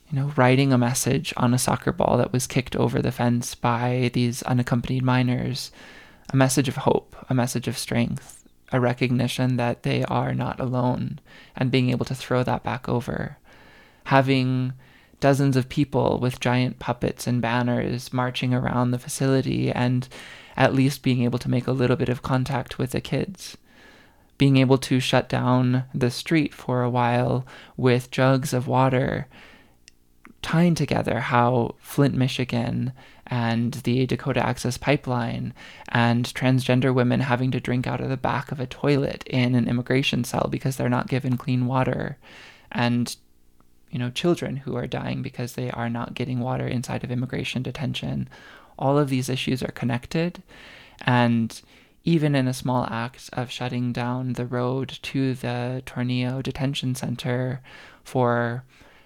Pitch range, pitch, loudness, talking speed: 120-130 Hz, 125 Hz, -24 LUFS, 160 wpm